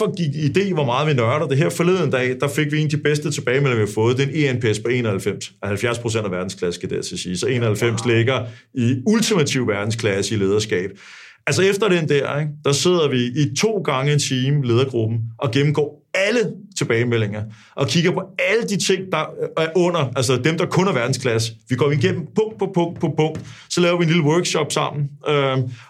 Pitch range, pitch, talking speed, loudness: 120-165 Hz, 145 Hz, 215 wpm, -20 LUFS